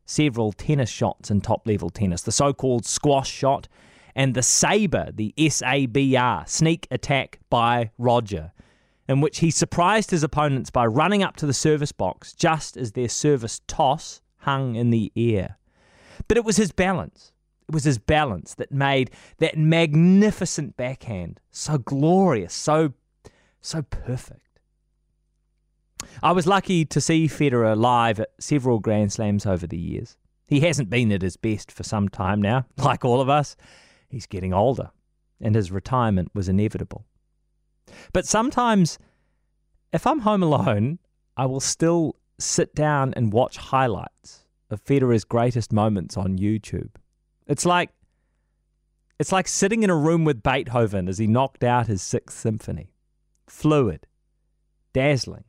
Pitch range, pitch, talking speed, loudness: 110-155 Hz, 130 Hz, 145 wpm, -22 LUFS